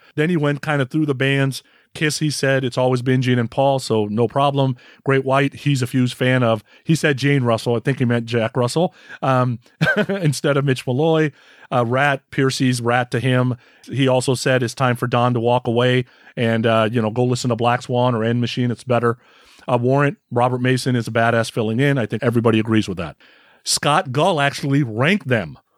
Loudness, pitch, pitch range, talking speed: -19 LUFS, 125 Hz, 120-140 Hz, 215 wpm